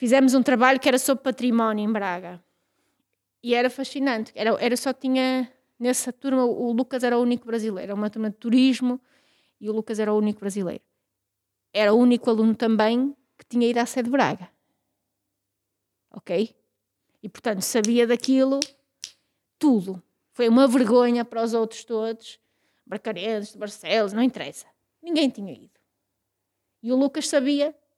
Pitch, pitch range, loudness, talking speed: 240 Hz, 215-260 Hz, -23 LUFS, 155 wpm